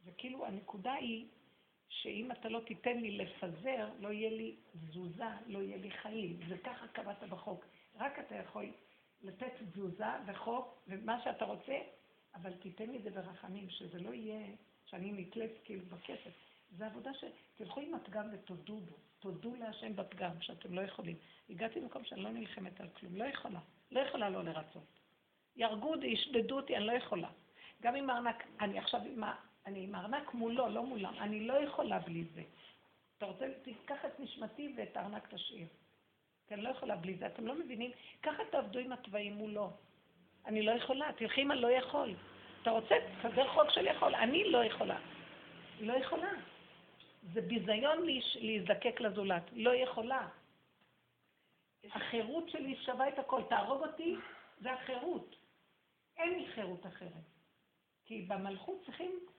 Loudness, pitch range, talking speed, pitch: -40 LUFS, 195-255 Hz, 160 wpm, 225 Hz